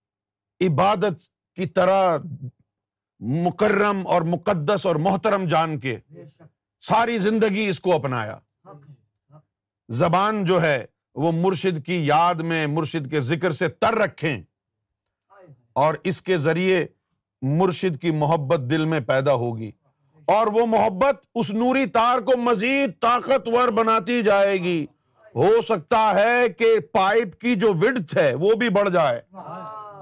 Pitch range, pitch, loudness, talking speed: 145-215 Hz, 180 Hz, -21 LUFS, 130 wpm